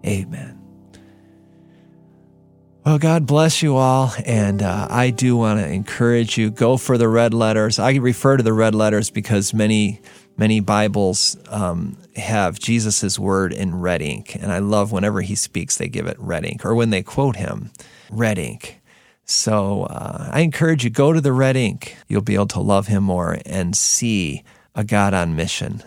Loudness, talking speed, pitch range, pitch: -18 LUFS, 180 wpm, 100-125 Hz, 105 Hz